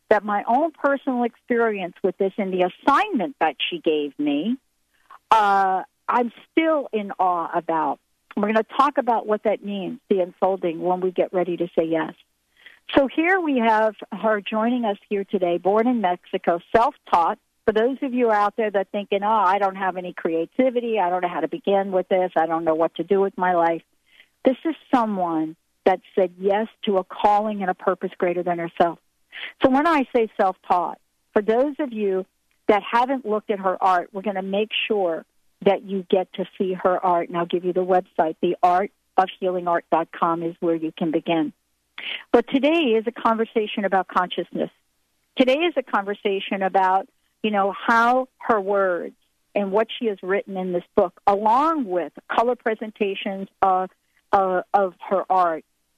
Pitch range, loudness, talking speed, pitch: 180-225 Hz, -22 LUFS, 180 wpm, 195 Hz